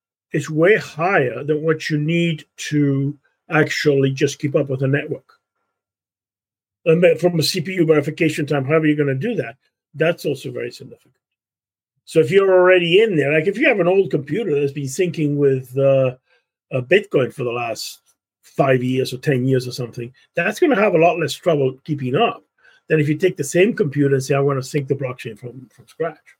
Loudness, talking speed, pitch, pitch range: -18 LUFS, 200 wpm, 145 Hz, 130-160 Hz